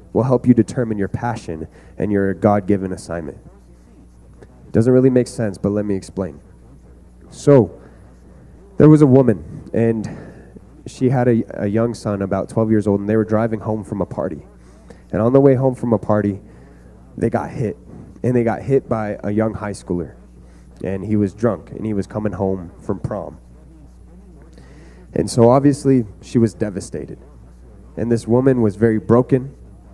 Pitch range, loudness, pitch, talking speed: 80-115 Hz, -18 LUFS, 105 Hz, 175 wpm